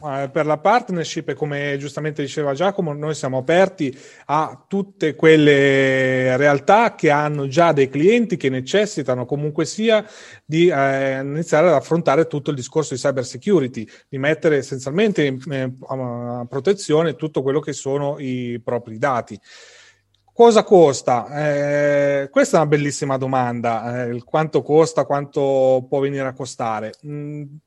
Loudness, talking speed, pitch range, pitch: -19 LUFS, 135 wpm, 135-155 Hz, 145 Hz